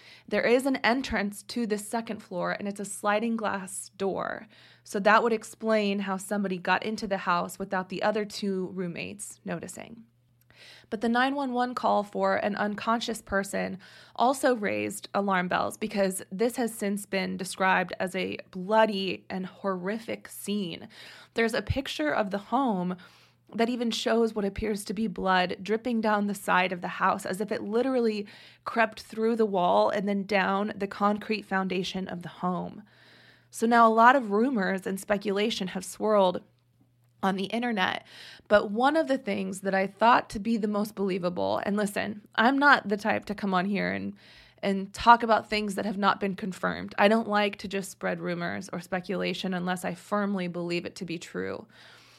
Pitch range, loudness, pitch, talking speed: 190-220 Hz, -28 LUFS, 205 Hz, 180 wpm